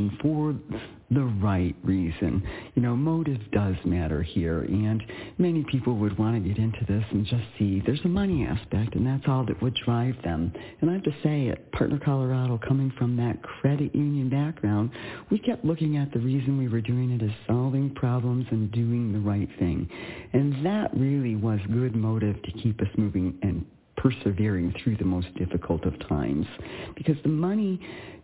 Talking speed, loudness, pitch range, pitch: 185 wpm, -27 LUFS, 100-135 Hz, 115 Hz